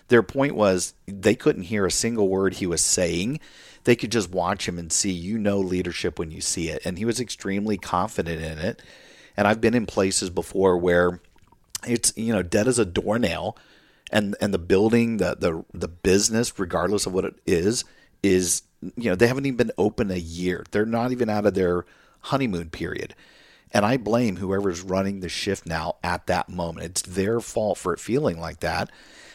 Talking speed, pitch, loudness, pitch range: 200 wpm, 95 Hz, -24 LUFS, 90-110 Hz